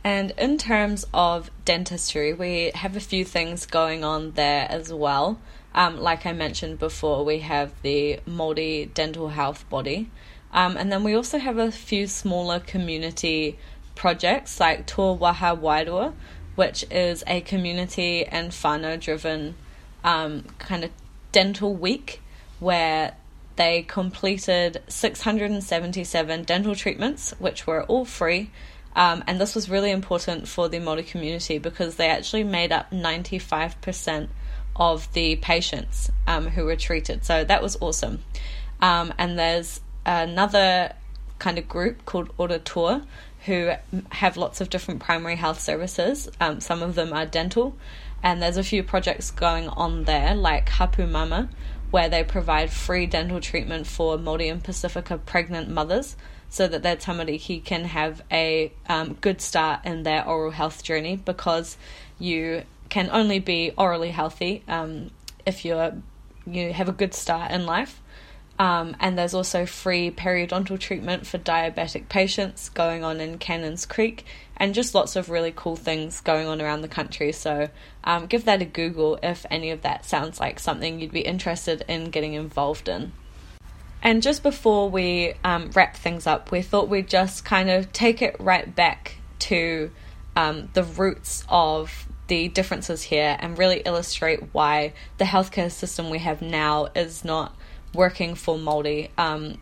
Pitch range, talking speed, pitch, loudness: 160-185 Hz, 155 wpm, 170 Hz, -24 LUFS